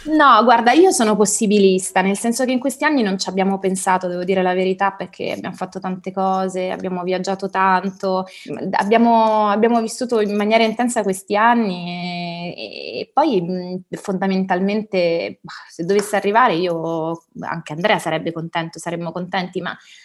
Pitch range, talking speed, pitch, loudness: 180-220 Hz, 155 wpm, 190 Hz, -18 LUFS